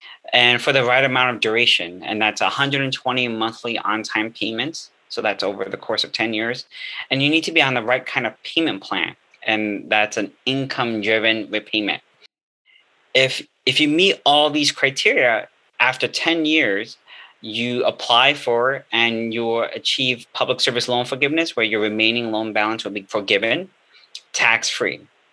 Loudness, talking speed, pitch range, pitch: -19 LUFS, 165 wpm, 110-135 Hz, 120 Hz